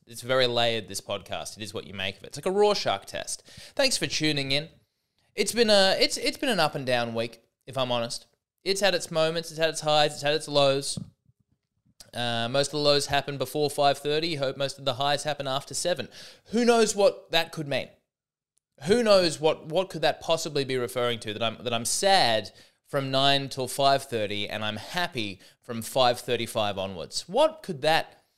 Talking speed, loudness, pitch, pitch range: 215 wpm, -26 LUFS, 140 Hz, 120-165 Hz